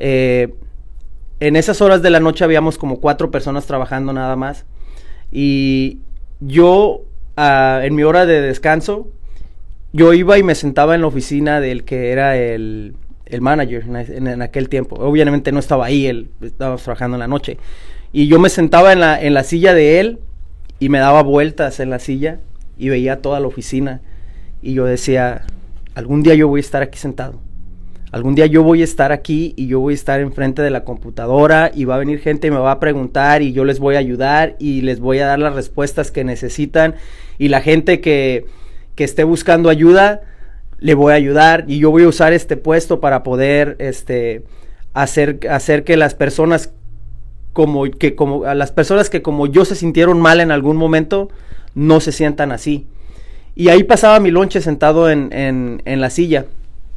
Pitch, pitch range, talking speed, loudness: 140 Hz, 130-155 Hz, 195 wpm, -13 LUFS